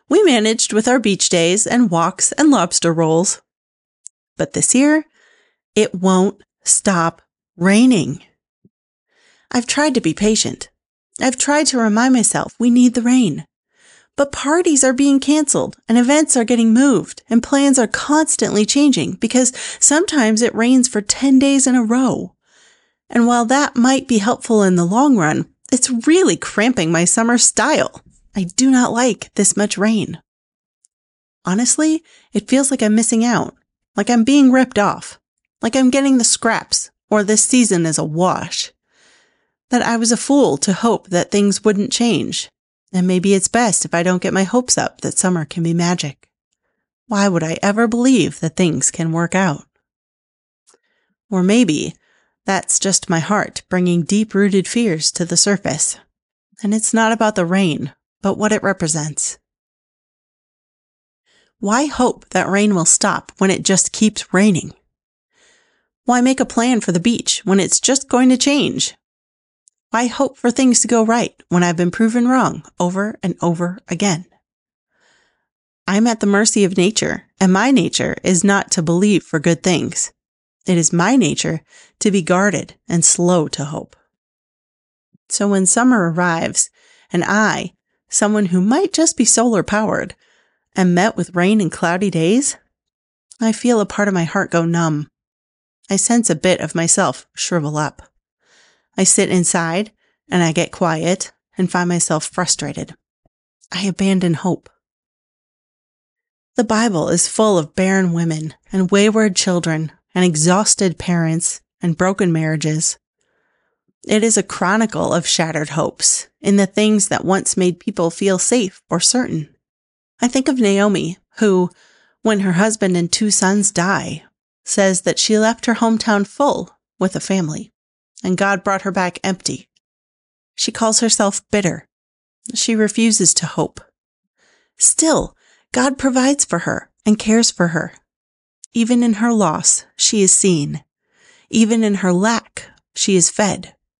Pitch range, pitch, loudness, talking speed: 180-240 Hz, 205 Hz, -15 LUFS, 155 wpm